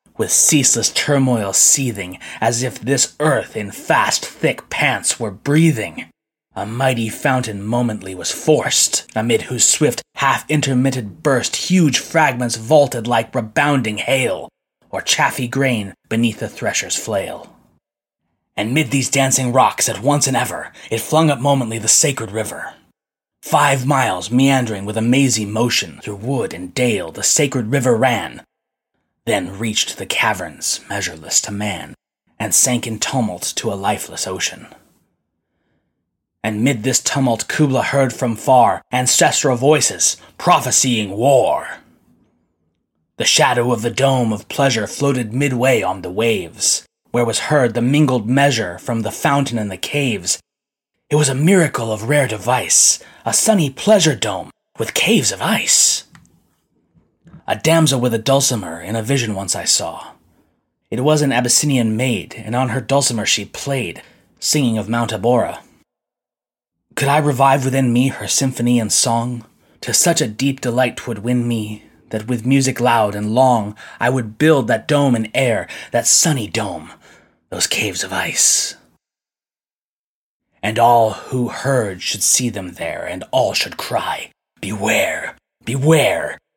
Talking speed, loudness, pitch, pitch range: 145 wpm, -16 LUFS, 125 Hz, 115-140 Hz